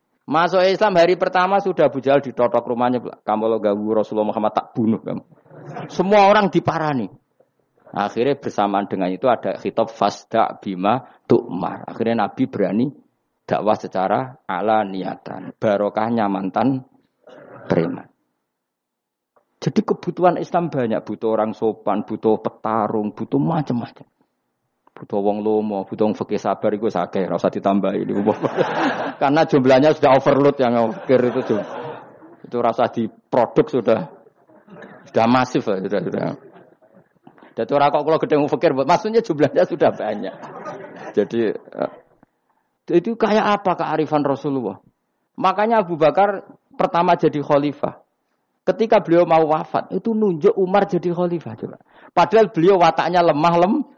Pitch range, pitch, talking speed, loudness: 110-175 Hz, 140 Hz, 125 wpm, -19 LUFS